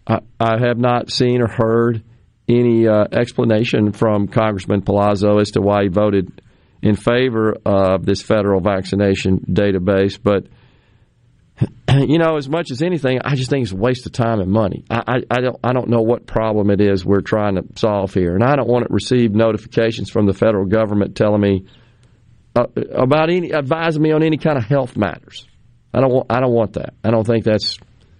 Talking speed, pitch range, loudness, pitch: 195 wpm, 100-125 Hz, -17 LUFS, 115 Hz